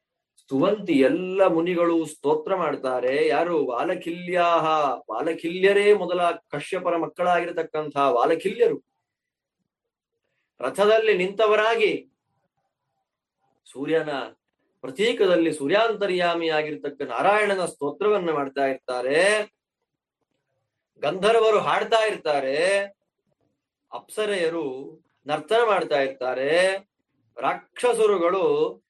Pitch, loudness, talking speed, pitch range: 180 Hz, -23 LUFS, 60 wpm, 155-215 Hz